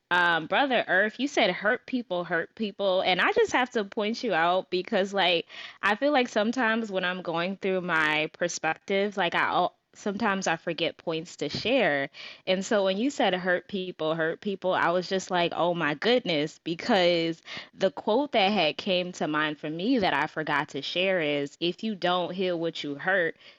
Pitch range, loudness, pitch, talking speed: 165-210 Hz, -27 LUFS, 185 Hz, 195 wpm